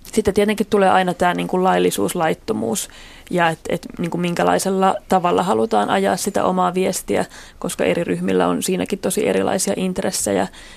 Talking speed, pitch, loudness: 150 wpm, 180 Hz, -19 LUFS